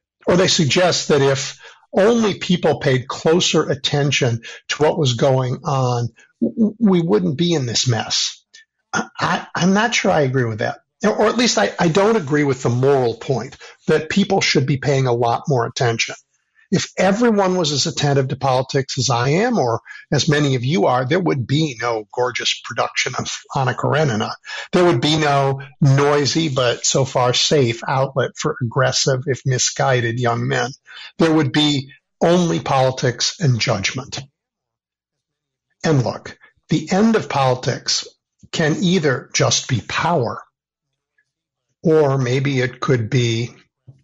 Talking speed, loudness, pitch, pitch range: 155 wpm, -18 LUFS, 140 Hz, 130-165 Hz